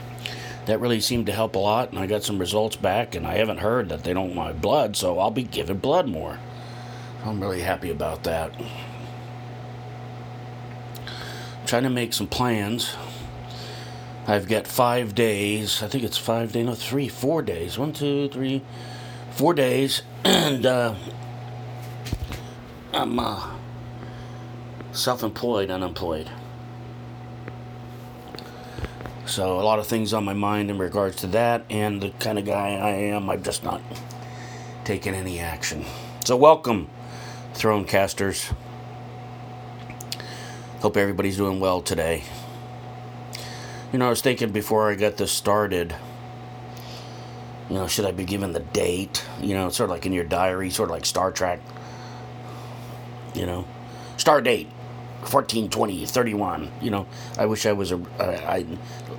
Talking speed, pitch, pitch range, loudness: 145 wpm, 120 Hz, 105-125 Hz, -24 LUFS